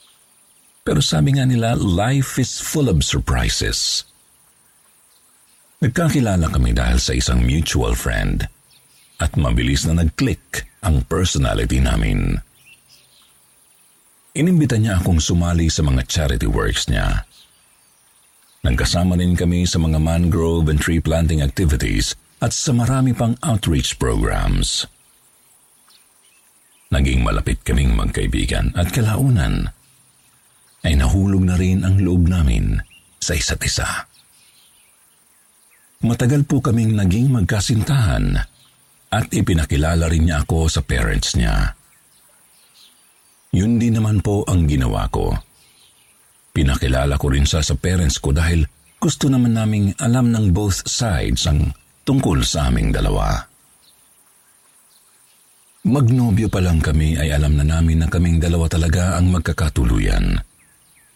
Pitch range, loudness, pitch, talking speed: 75-110 Hz, -18 LUFS, 85 Hz, 115 wpm